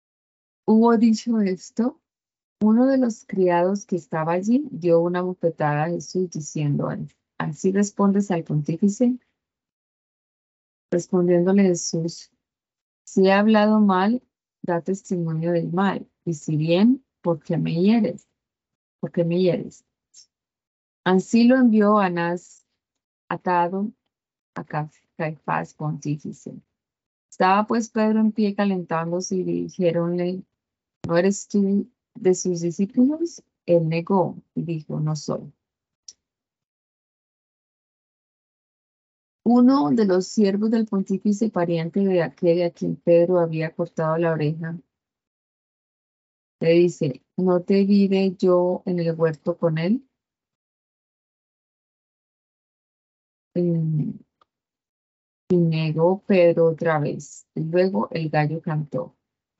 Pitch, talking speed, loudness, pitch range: 180 Hz, 110 wpm, -22 LUFS, 165-205 Hz